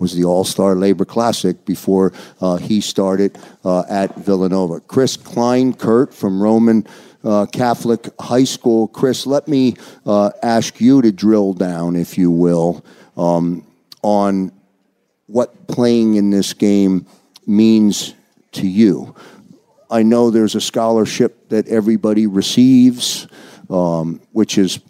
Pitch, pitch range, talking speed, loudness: 105 Hz, 95-115 Hz, 130 wpm, -15 LUFS